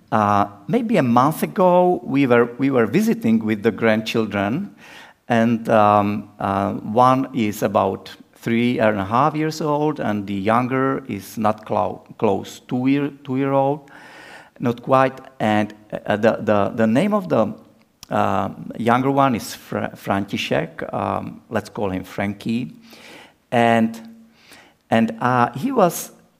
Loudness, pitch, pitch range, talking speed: -20 LUFS, 120 Hz, 110-140 Hz, 145 wpm